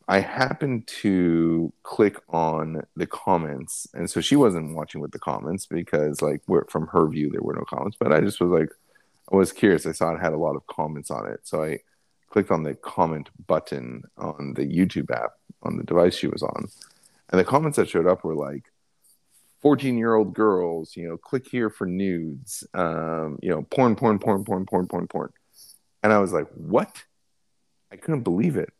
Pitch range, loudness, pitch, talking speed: 80-110 Hz, -24 LUFS, 90 Hz, 200 wpm